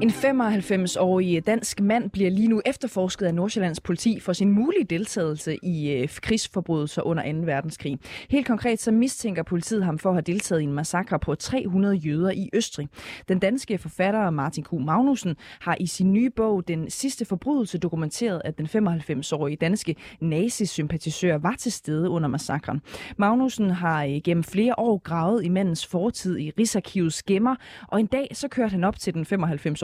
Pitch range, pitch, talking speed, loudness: 160-220 Hz, 185 Hz, 170 wpm, -25 LUFS